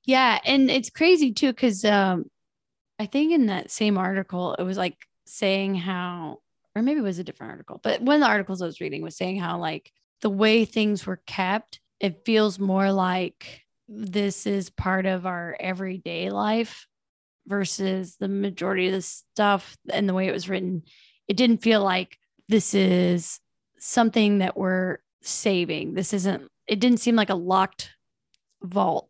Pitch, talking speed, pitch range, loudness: 195 Hz, 175 wpm, 185-220 Hz, -24 LUFS